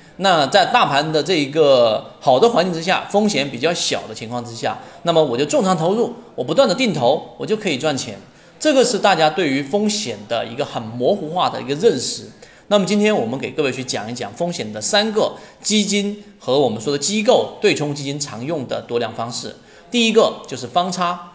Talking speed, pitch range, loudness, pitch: 310 characters per minute, 145-210 Hz, -18 LUFS, 180 Hz